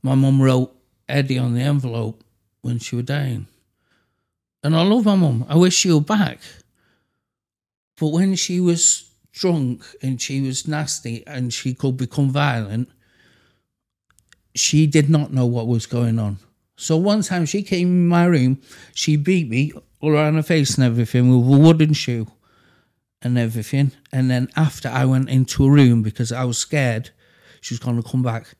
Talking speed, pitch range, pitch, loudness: 175 wpm, 120-155 Hz, 130 Hz, -19 LUFS